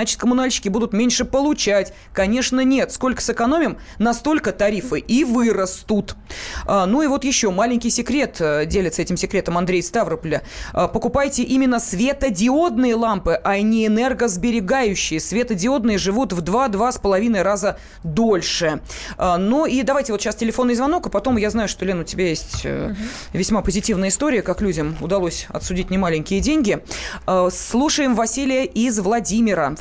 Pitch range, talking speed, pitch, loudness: 195-255 Hz, 135 wpm, 225 Hz, -19 LUFS